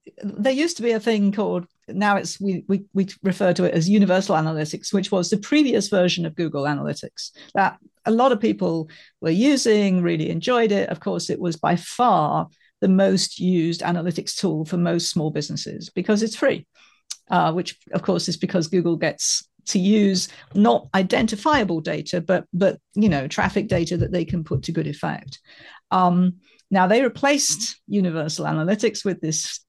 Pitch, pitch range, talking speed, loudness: 185 Hz, 170-210 Hz, 180 wpm, -21 LUFS